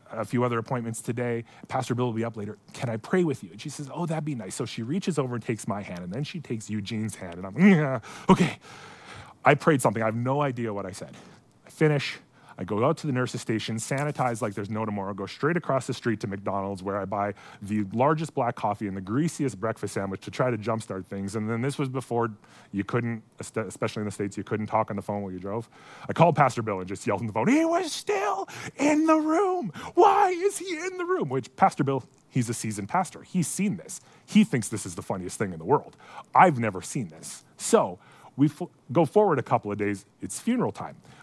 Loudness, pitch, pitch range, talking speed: -27 LUFS, 120 Hz, 105-150 Hz, 245 wpm